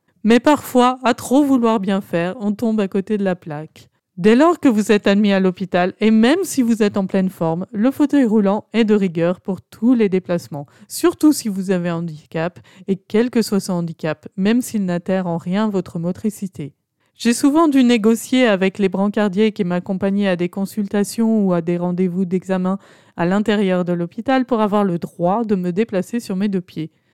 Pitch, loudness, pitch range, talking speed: 200 Hz, -18 LUFS, 180-225 Hz, 200 wpm